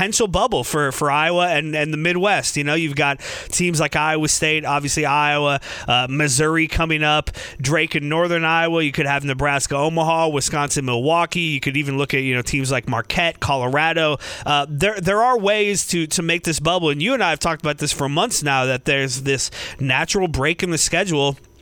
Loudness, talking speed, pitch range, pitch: -19 LUFS, 205 wpm, 140-165 Hz, 150 Hz